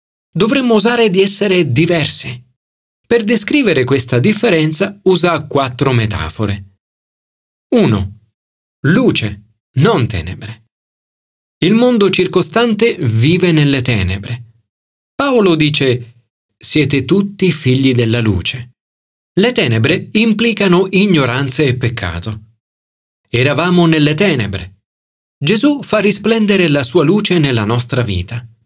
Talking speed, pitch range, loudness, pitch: 100 wpm, 110-185 Hz, -13 LUFS, 135 Hz